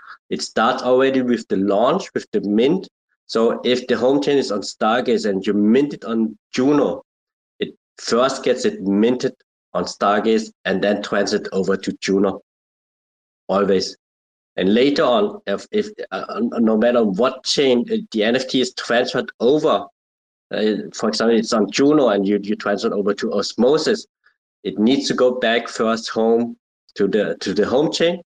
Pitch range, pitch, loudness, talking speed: 100-125 Hz, 115 Hz, -19 LUFS, 170 wpm